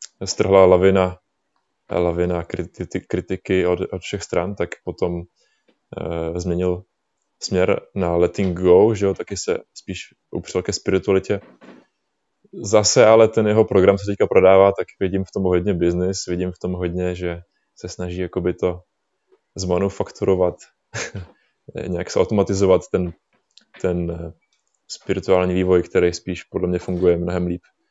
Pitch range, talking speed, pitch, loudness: 90-95 Hz, 135 wpm, 90 Hz, -20 LUFS